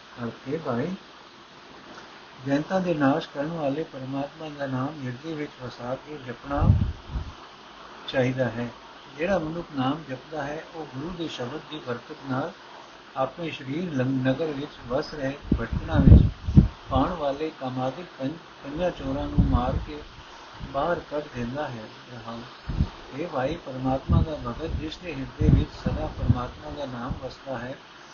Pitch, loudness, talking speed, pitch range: 135 Hz, -27 LUFS, 135 wpm, 125-155 Hz